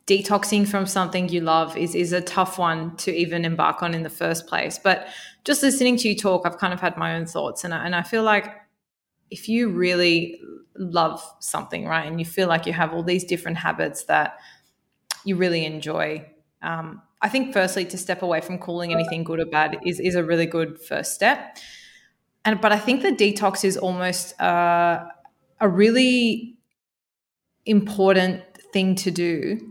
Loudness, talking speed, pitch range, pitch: -22 LUFS, 185 wpm, 165-205 Hz, 180 Hz